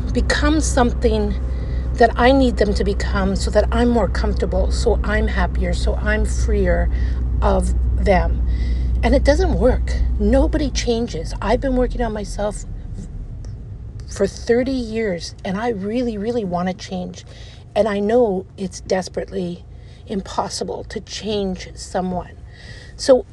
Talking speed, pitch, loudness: 135 wpm, 175 Hz, -20 LUFS